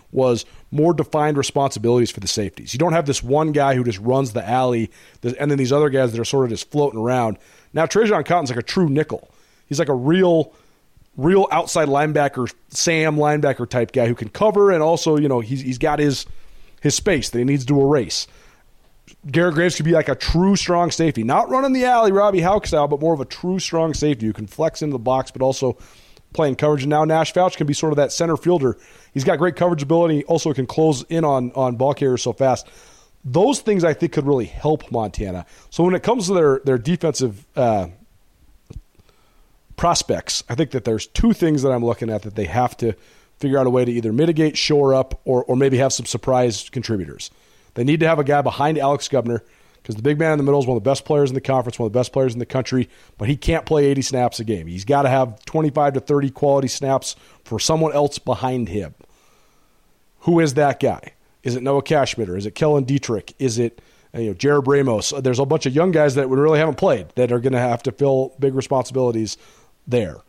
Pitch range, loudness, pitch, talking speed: 125-155 Hz, -19 LUFS, 140 Hz, 230 wpm